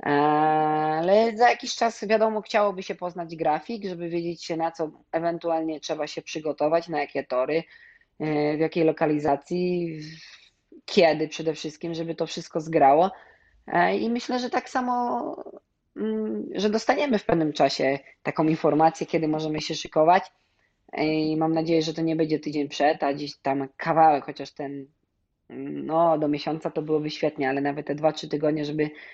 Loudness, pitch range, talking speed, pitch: -25 LUFS, 150-170 Hz, 155 wpm, 160 Hz